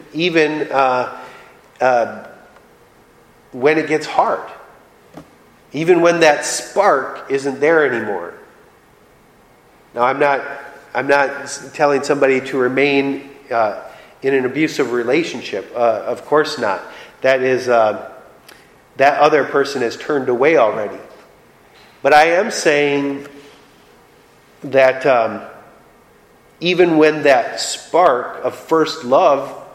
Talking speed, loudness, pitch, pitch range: 110 wpm, -16 LUFS, 140 Hz, 130-150 Hz